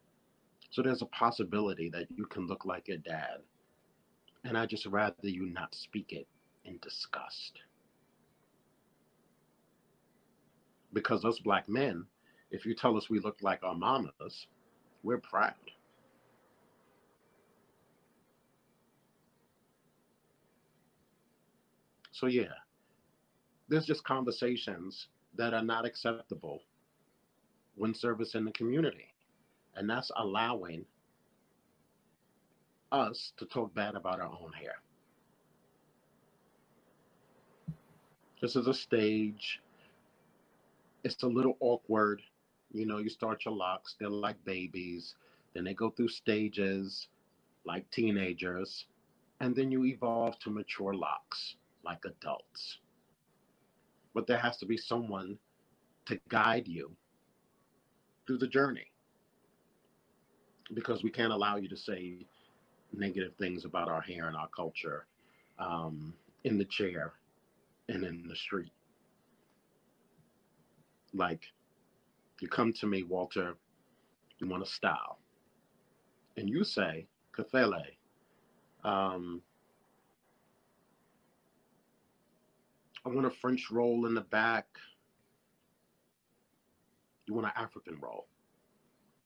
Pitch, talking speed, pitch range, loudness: 110 Hz, 105 wpm, 95-115 Hz, -35 LUFS